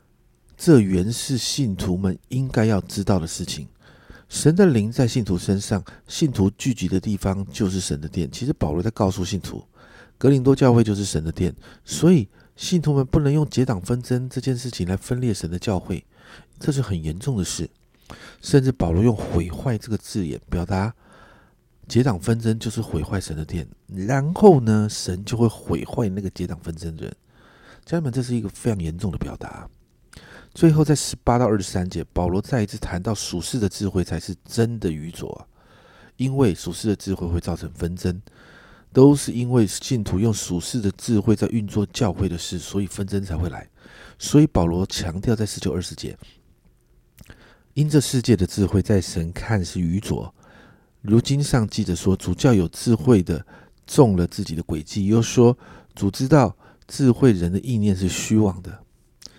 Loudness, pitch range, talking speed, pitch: -22 LUFS, 90-125 Hz, 265 characters per minute, 105 Hz